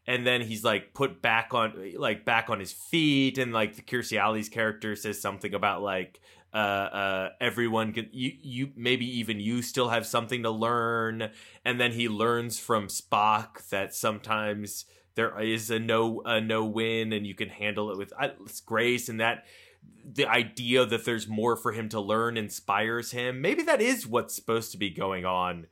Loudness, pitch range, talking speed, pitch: -28 LUFS, 105-120 Hz, 185 wpm, 110 Hz